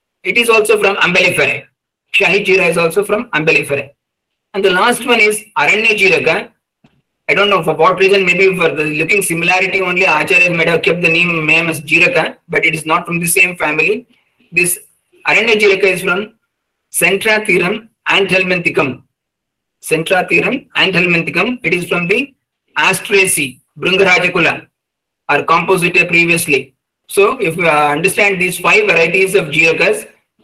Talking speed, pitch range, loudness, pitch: 150 wpm, 165-200 Hz, -11 LUFS, 180 Hz